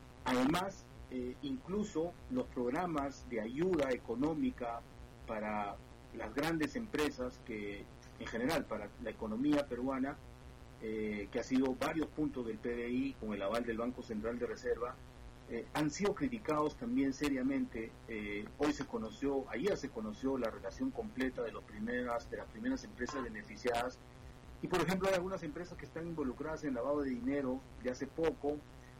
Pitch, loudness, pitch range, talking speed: 130 Hz, -39 LUFS, 120-150 Hz, 155 wpm